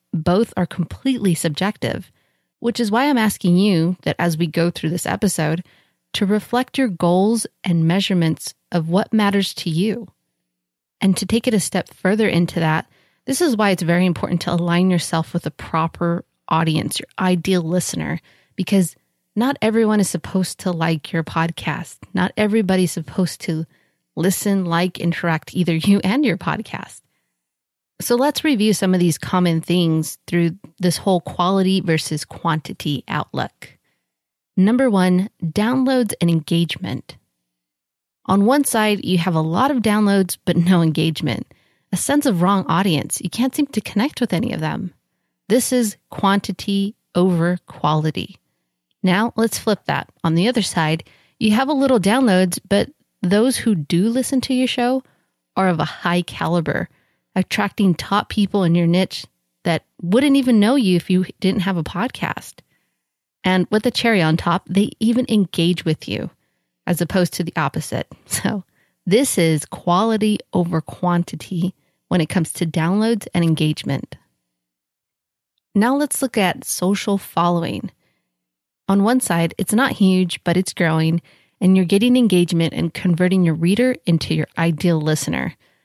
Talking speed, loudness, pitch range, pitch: 155 wpm, -19 LUFS, 165-210 Hz, 180 Hz